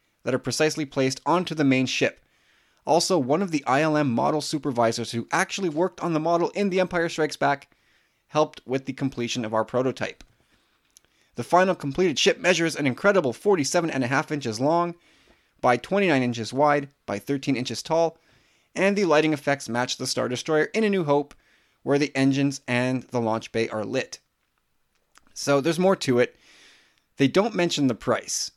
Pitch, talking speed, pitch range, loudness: 140 Hz, 180 wpm, 125-165 Hz, -24 LUFS